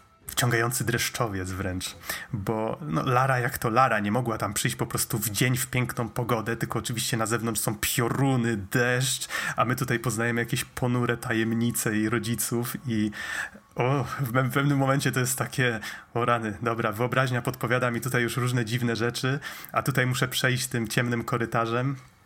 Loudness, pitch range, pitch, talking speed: -26 LUFS, 115-130 Hz, 120 Hz, 165 wpm